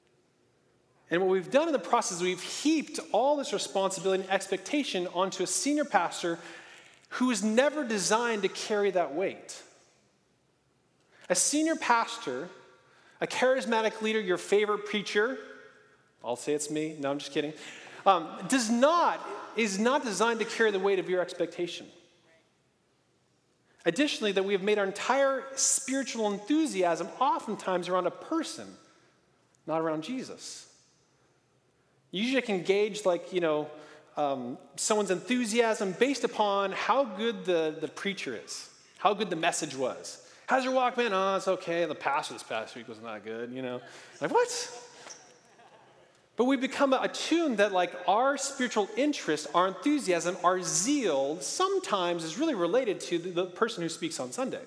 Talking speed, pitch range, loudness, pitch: 155 wpm, 175-255 Hz, -29 LUFS, 200 Hz